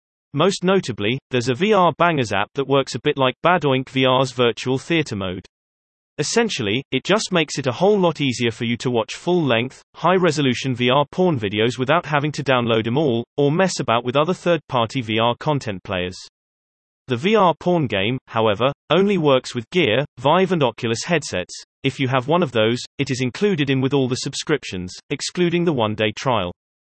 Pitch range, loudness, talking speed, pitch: 115-160 Hz, -20 LUFS, 190 wpm, 130 Hz